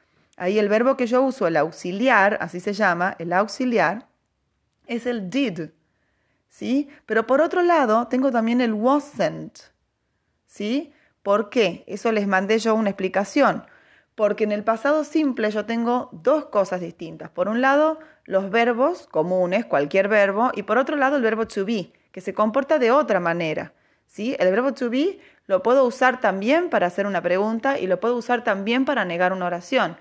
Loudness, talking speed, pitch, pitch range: -21 LUFS, 175 wpm, 225 Hz, 195-265 Hz